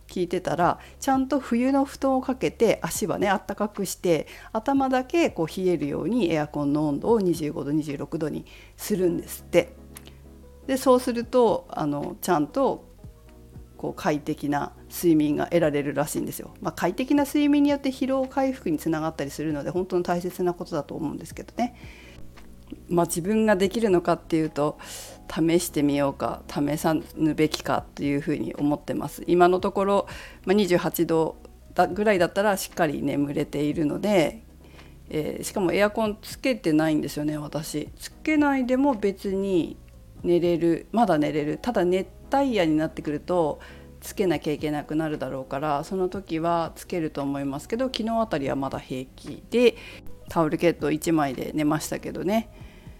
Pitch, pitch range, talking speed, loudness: 165 Hz, 145-205 Hz, 335 characters per minute, -25 LUFS